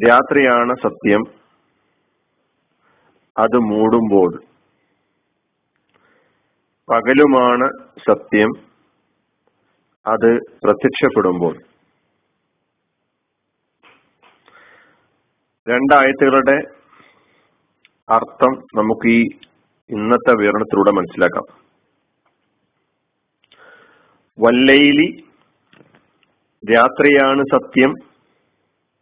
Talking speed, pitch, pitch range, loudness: 35 wpm, 125 Hz, 115-140 Hz, -15 LUFS